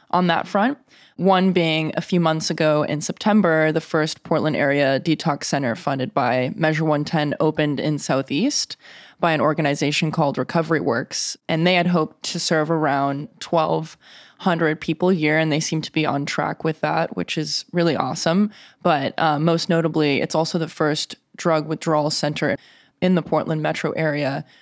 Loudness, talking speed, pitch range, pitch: -21 LUFS, 170 wpm, 150-170 Hz, 160 Hz